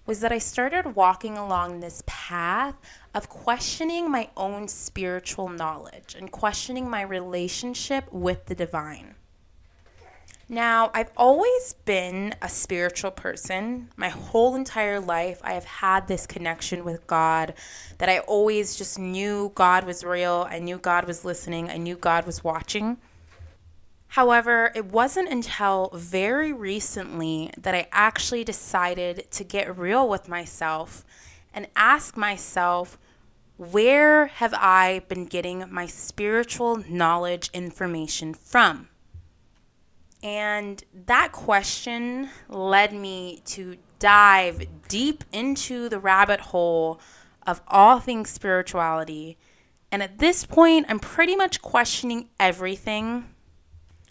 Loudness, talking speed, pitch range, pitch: -23 LUFS, 120 wpm, 175-230 Hz, 190 Hz